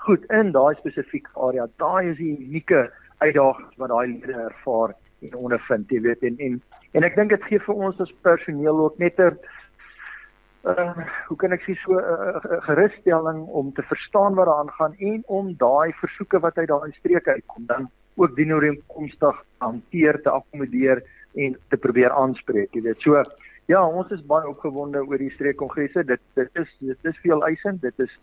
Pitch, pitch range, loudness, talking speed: 155 Hz, 135-175 Hz, -22 LUFS, 185 wpm